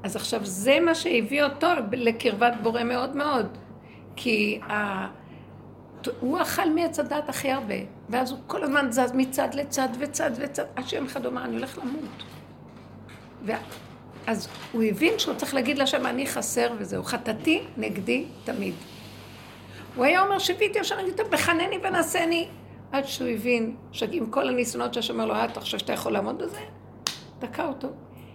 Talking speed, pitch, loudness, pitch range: 160 wpm, 275 Hz, -26 LUFS, 240-320 Hz